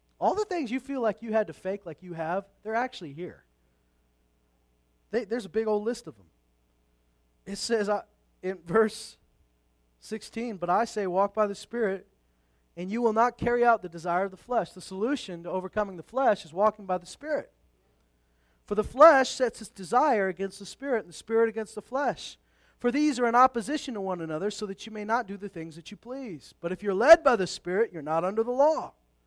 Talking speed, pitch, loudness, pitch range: 215 wpm, 200 Hz, -27 LUFS, 160-230 Hz